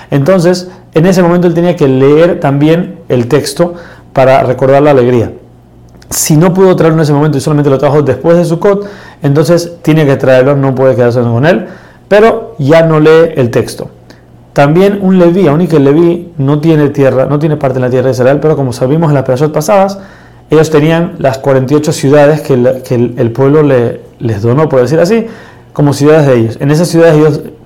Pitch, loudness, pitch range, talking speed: 150 Hz, -8 LUFS, 130-170 Hz, 205 wpm